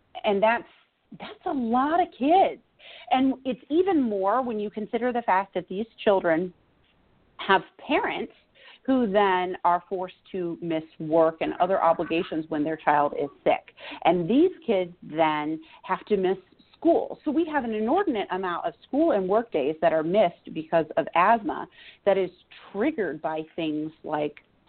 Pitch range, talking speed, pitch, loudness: 165-250 Hz, 165 wpm, 195 Hz, -25 LUFS